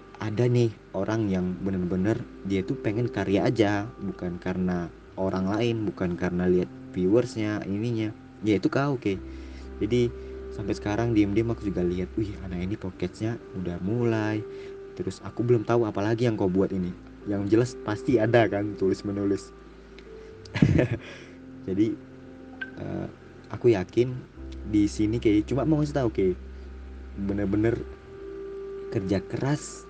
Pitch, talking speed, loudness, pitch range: 105 Hz, 140 wpm, -27 LUFS, 95-120 Hz